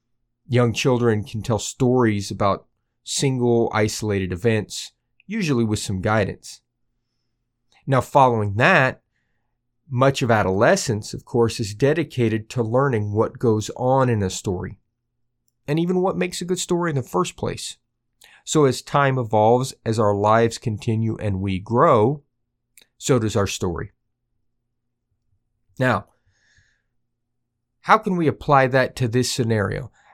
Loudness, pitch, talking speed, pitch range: -21 LUFS, 120 Hz, 130 wpm, 110-130 Hz